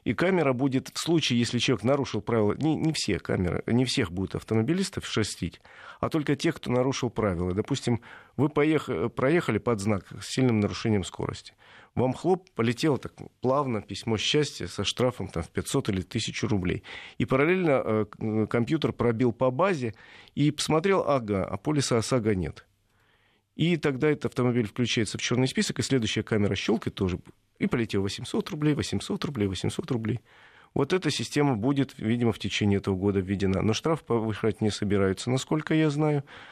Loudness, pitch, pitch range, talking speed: -27 LUFS, 120 Hz, 105-140 Hz, 170 wpm